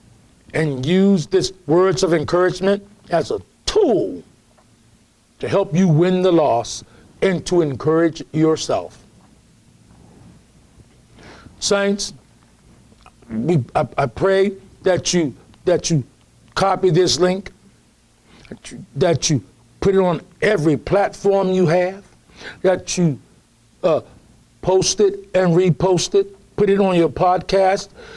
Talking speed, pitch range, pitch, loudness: 115 wpm, 150-195 Hz, 180 Hz, -18 LUFS